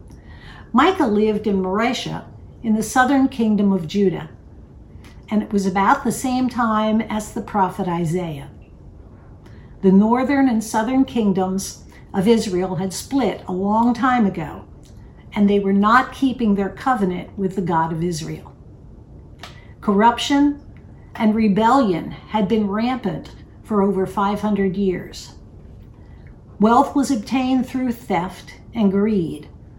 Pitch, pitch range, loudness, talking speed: 210 Hz, 185-235 Hz, -19 LUFS, 125 wpm